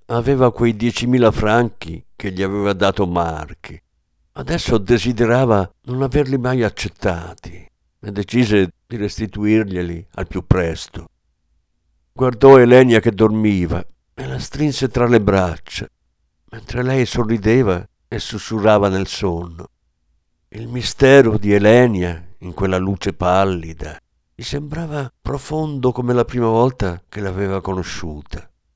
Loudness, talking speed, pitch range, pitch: -17 LUFS, 120 wpm, 85-120 Hz, 105 Hz